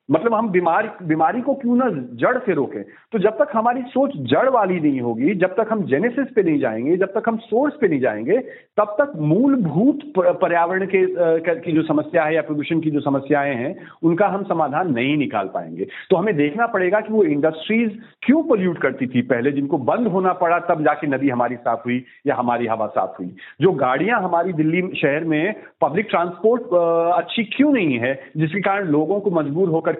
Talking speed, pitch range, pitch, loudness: 200 wpm, 150-220 Hz, 175 Hz, -19 LUFS